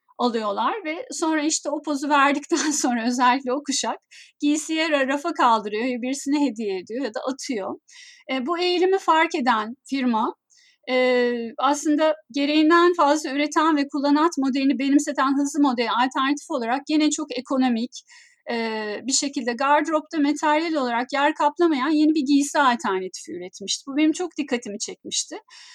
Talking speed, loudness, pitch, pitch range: 140 wpm, -22 LUFS, 285 Hz, 255-315 Hz